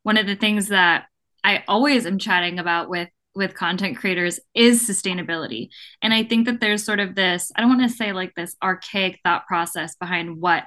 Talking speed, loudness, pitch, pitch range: 205 wpm, -20 LUFS, 190 Hz, 175-215 Hz